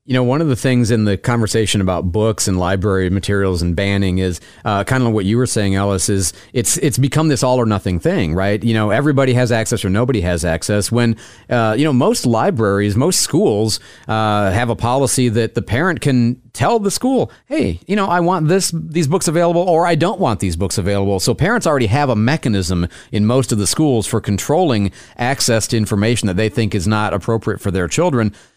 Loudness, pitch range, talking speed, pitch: -16 LUFS, 100-130 Hz, 220 wpm, 115 Hz